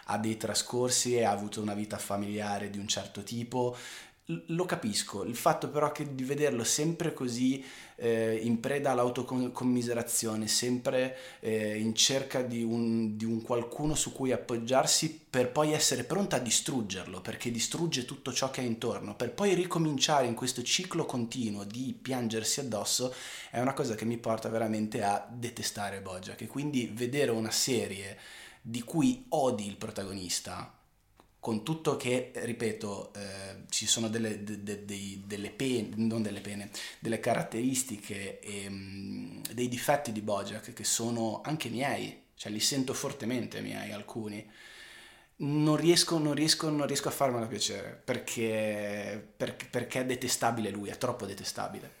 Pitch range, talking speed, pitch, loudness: 105-130 Hz, 155 wpm, 120 Hz, -32 LUFS